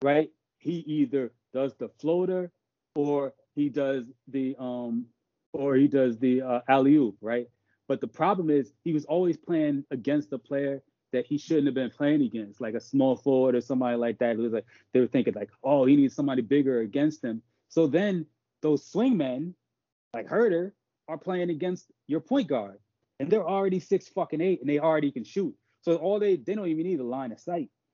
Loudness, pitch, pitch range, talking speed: -27 LUFS, 145 Hz, 125-170 Hz, 200 wpm